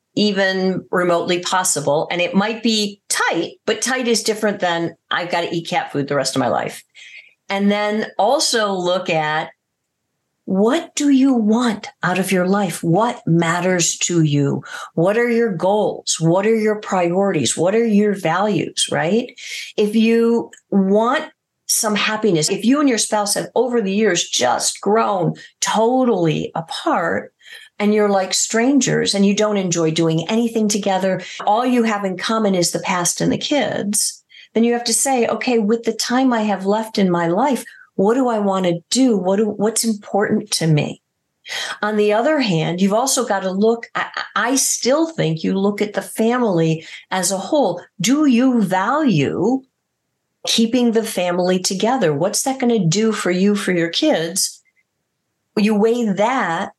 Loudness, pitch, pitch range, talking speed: -18 LUFS, 210 Hz, 185-230 Hz, 170 wpm